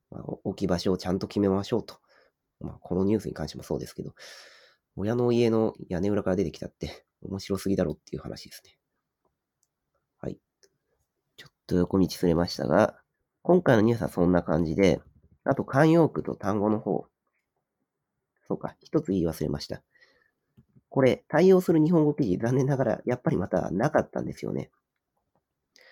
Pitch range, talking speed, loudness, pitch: 90-135 Hz, 345 characters per minute, -26 LUFS, 100 Hz